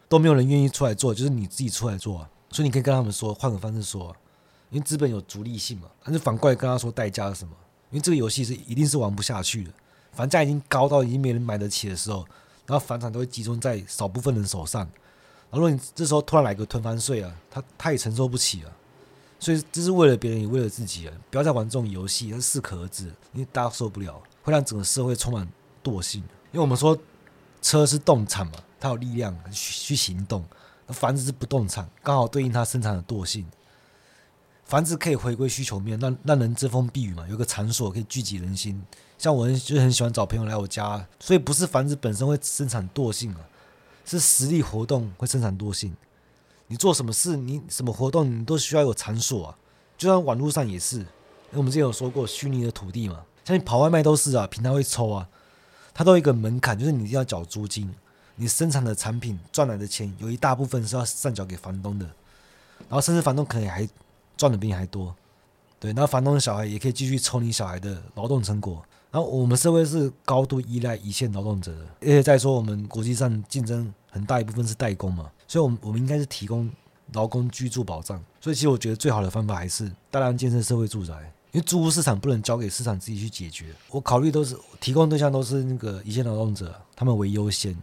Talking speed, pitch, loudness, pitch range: 350 characters per minute, 120 Hz, -24 LUFS, 105-140 Hz